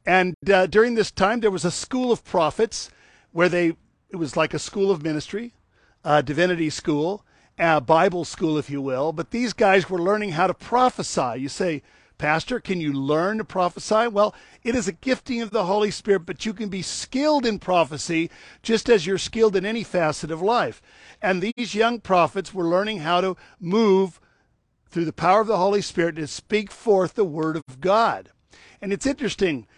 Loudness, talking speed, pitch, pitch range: -22 LUFS, 195 wpm, 190 Hz, 165-215 Hz